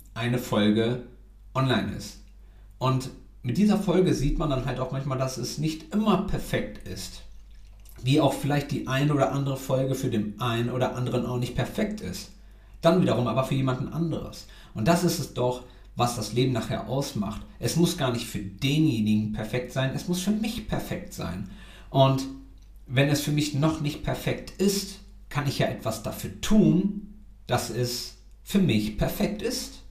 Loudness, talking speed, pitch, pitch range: -27 LUFS, 175 wpm, 130 Hz, 110-155 Hz